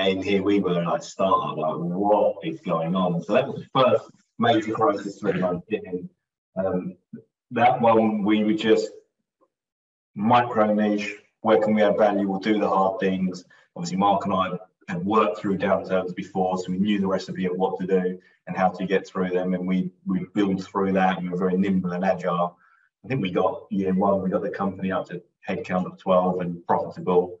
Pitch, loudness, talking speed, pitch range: 95 Hz, -24 LUFS, 210 wpm, 90-100 Hz